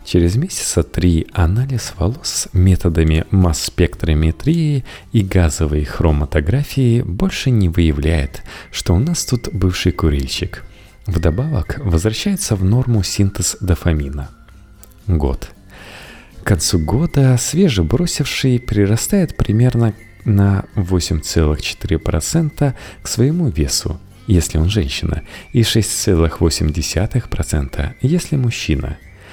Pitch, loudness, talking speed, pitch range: 95 Hz, -17 LUFS, 90 wpm, 80-115 Hz